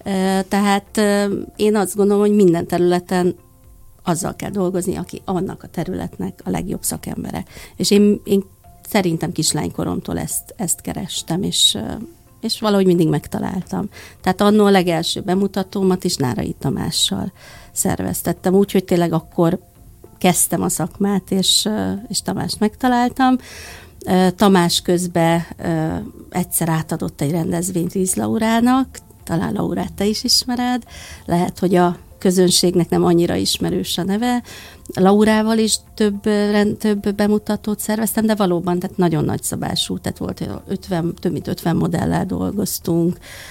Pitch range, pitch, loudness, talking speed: 175-210 Hz, 190 Hz, -18 LUFS, 125 wpm